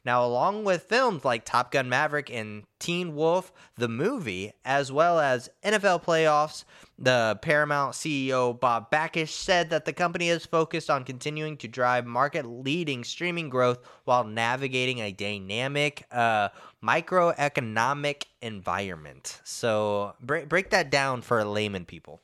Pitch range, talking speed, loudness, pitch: 120-160 Hz, 140 wpm, -26 LUFS, 135 Hz